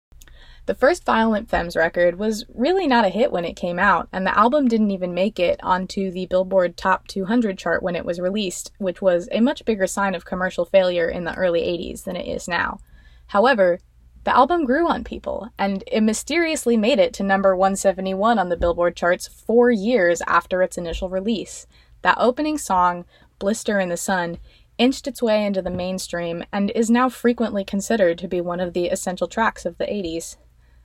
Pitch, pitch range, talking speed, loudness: 190 Hz, 175-225 Hz, 195 wpm, -21 LUFS